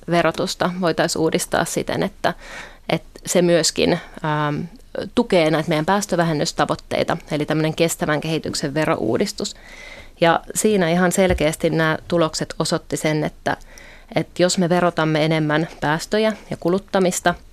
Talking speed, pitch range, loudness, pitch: 120 wpm, 155-180 Hz, -20 LUFS, 165 Hz